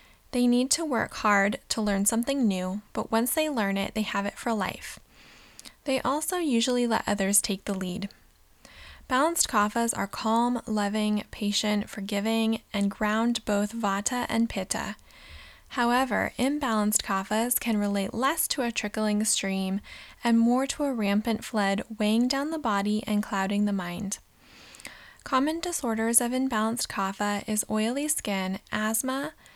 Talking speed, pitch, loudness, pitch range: 150 wpm, 220 Hz, -27 LUFS, 205-245 Hz